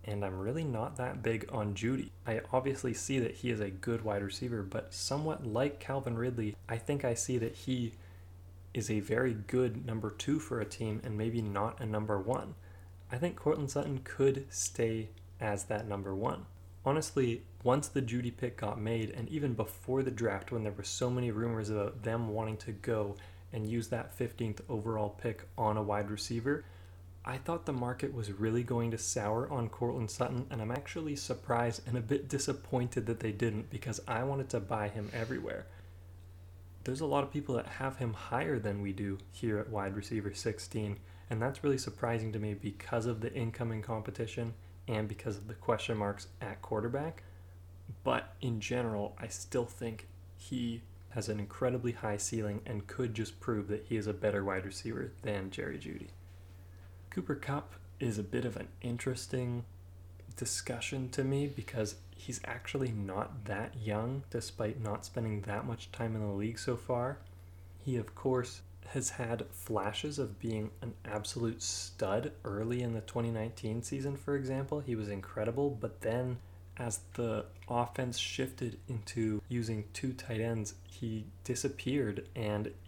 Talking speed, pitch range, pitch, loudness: 175 wpm, 100-125 Hz, 110 Hz, -37 LUFS